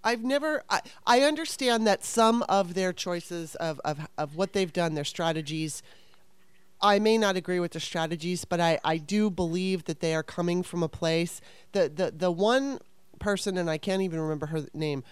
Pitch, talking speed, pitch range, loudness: 180 Hz, 195 wpm, 165-205 Hz, -28 LUFS